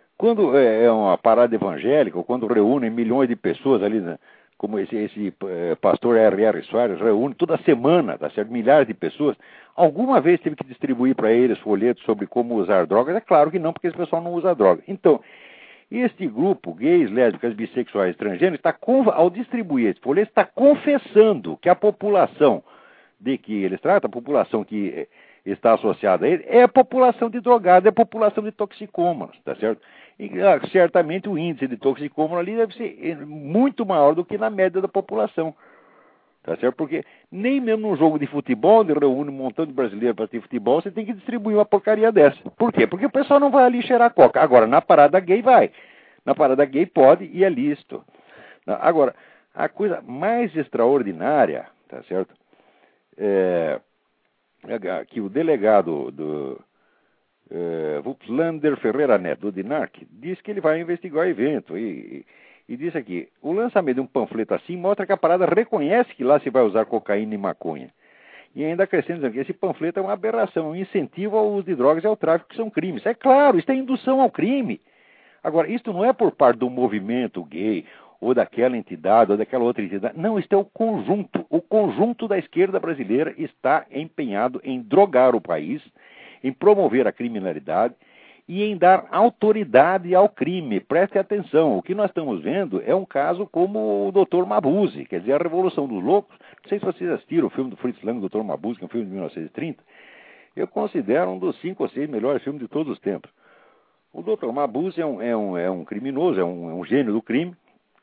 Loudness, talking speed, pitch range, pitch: -20 LUFS, 185 wpm, 130-215 Hz, 180 Hz